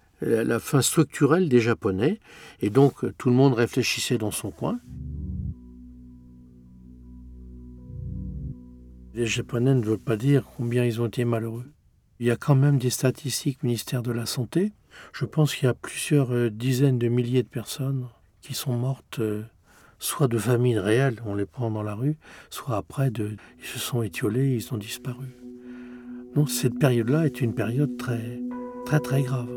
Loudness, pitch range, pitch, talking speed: -25 LUFS, 105-130 Hz, 120 Hz, 165 wpm